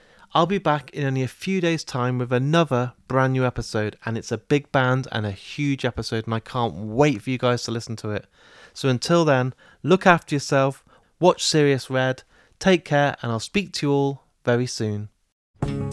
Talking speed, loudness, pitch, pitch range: 200 wpm, -23 LUFS, 130 Hz, 115-145 Hz